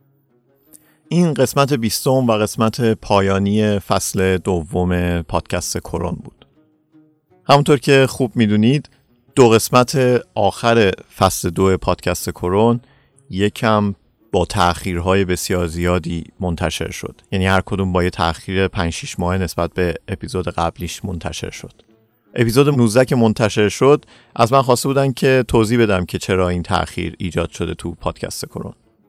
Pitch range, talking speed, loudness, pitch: 90-125 Hz, 135 wpm, -17 LUFS, 105 Hz